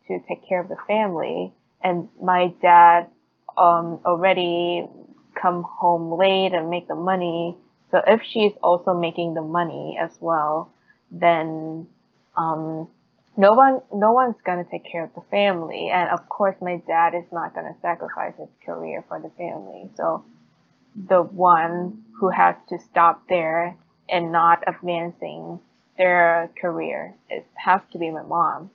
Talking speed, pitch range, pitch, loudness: 155 wpm, 170-185 Hz, 175 Hz, -21 LUFS